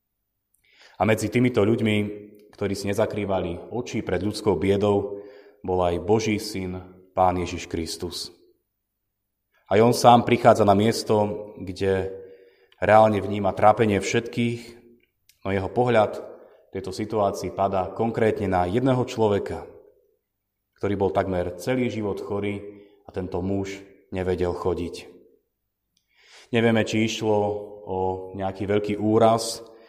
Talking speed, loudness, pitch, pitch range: 115 wpm, -23 LUFS, 100 Hz, 95-110 Hz